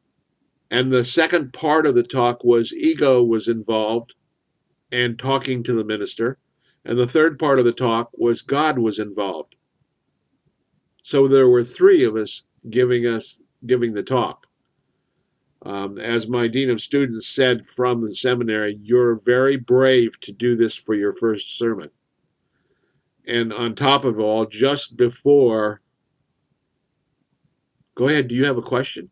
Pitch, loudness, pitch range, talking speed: 120 Hz, -19 LUFS, 115-130 Hz, 150 wpm